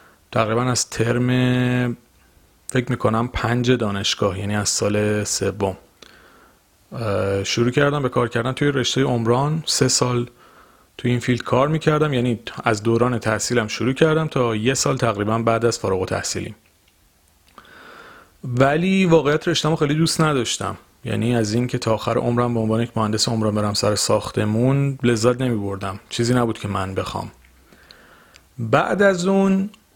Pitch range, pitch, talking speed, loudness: 110-135 Hz, 120 Hz, 145 wpm, -20 LUFS